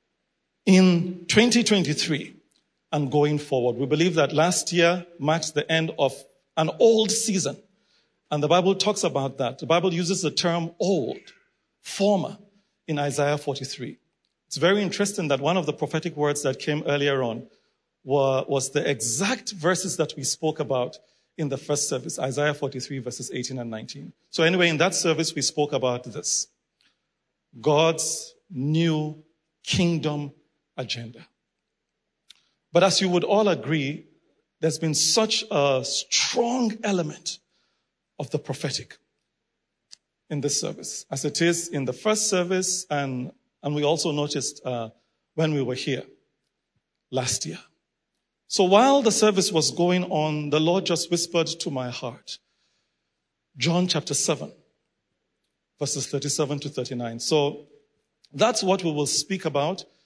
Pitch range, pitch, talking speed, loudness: 140-180 Hz, 155 Hz, 145 wpm, -24 LUFS